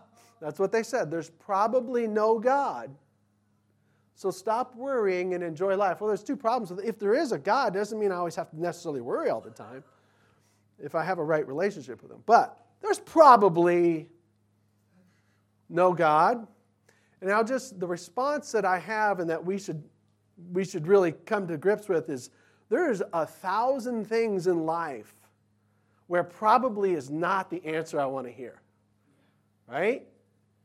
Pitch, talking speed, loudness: 175 Hz, 170 wpm, -27 LUFS